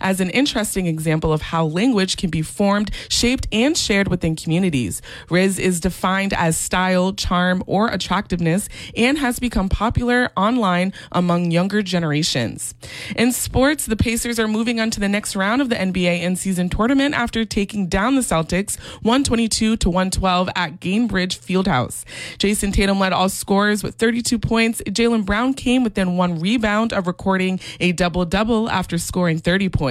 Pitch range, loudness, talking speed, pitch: 180-225 Hz, -19 LUFS, 165 wpm, 195 Hz